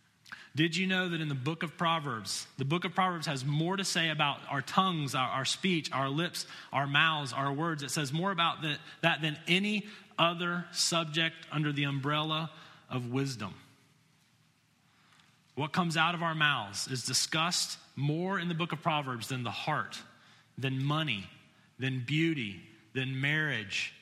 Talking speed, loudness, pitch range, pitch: 165 wpm, -31 LUFS, 135-170 Hz, 155 Hz